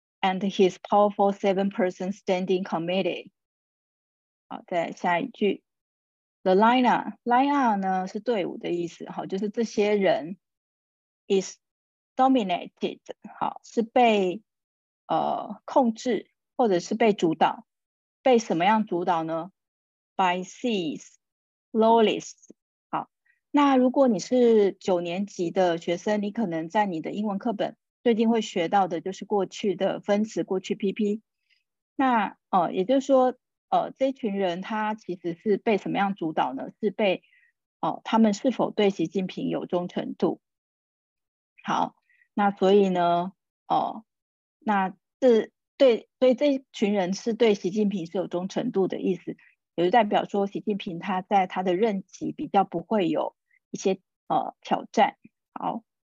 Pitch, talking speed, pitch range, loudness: 205 Hz, 265 characters per minute, 185-230 Hz, -25 LUFS